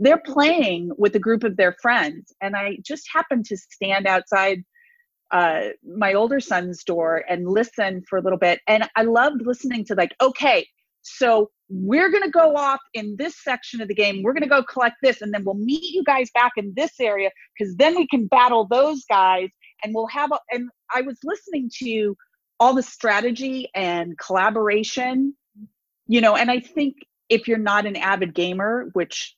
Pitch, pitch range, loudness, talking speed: 230 Hz, 200-275 Hz, -20 LUFS, 190 wpm